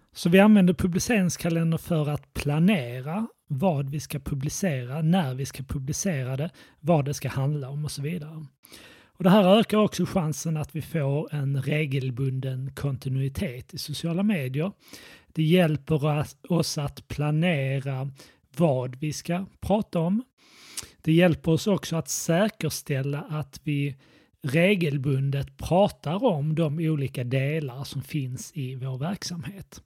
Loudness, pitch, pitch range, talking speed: -26 LUFS, 150 Hz, 140-170 Hz, 135 wpm